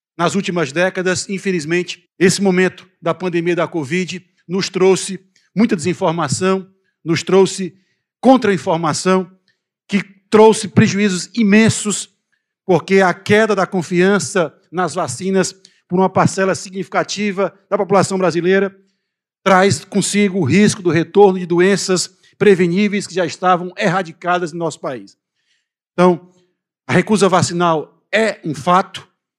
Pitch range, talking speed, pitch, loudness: 175-195 Hz, 120 wpm, 185 Hz, -16 LUFS